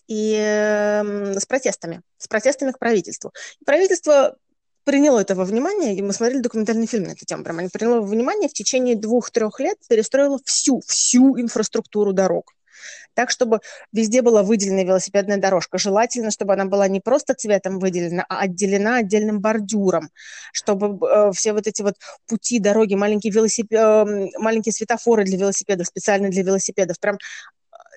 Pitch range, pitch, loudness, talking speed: 200-240 Hz, 215 Hz, -19 LUFS, 155 wpm